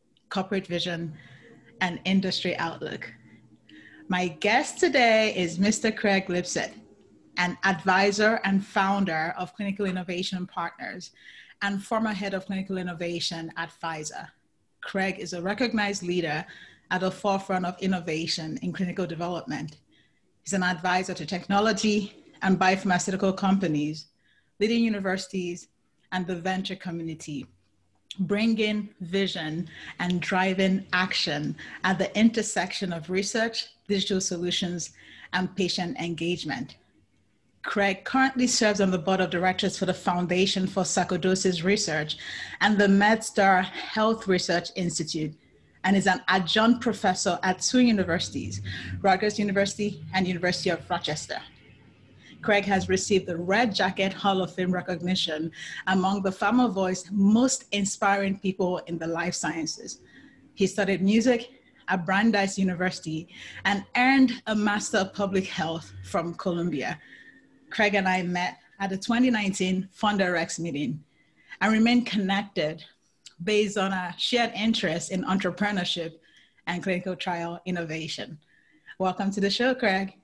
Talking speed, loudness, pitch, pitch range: 125 wpm, -26 LUFS, 190 Hz, 175-200 Hz